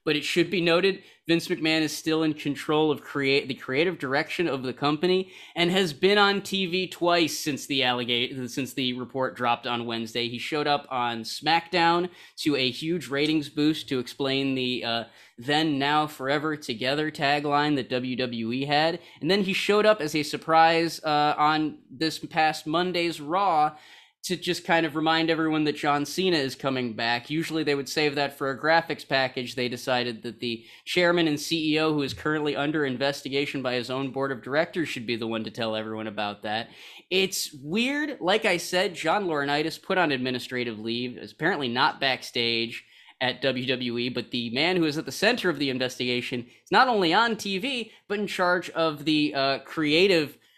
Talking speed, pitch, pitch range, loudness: 185 wpm, 150 Hz, 130-165 Hz, -25 LUFS